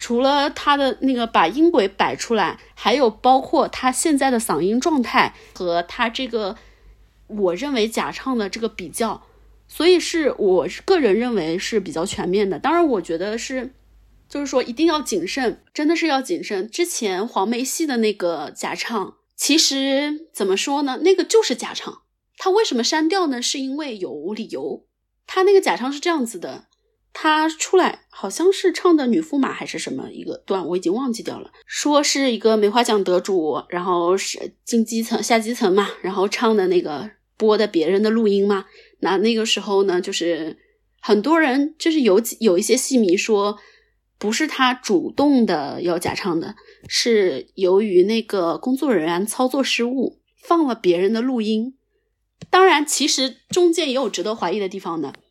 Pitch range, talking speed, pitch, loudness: 210-315 Hz, 260 characters per minute, 250 Hz, -20 LUFS